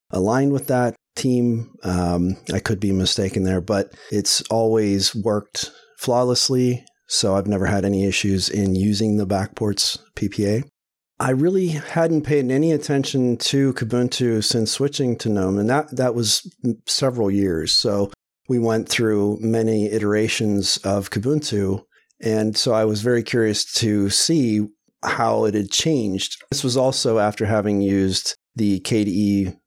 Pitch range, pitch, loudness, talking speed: 100-125 Hz, 110 Hz, -20 LUFS, 150 wpm